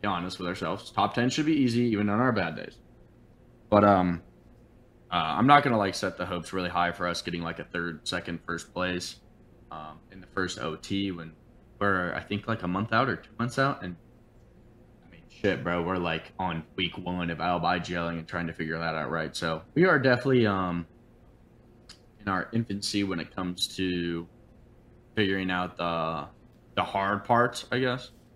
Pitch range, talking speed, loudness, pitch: 85-115 Hz, 195 wpm, -28 LUFS, 95 Hz